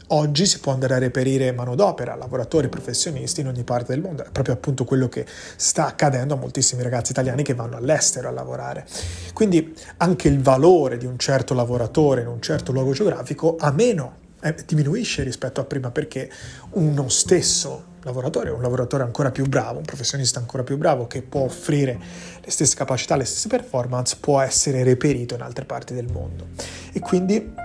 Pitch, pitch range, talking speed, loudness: 135 Hz, 125-150 Hz, 180 wpm, -21 LUFS